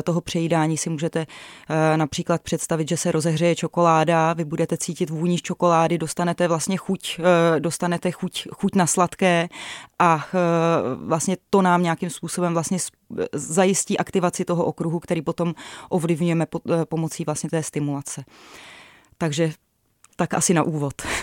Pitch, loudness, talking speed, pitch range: 170 Hz, -22 LUFS, 145 wpm, 160-175 Hz